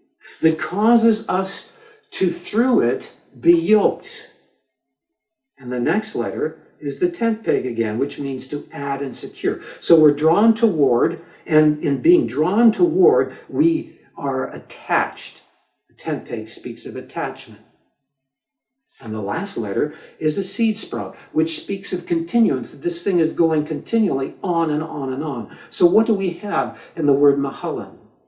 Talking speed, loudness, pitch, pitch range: 155 wpm, -20 LUFS, 170 Hz, 140-225 Hz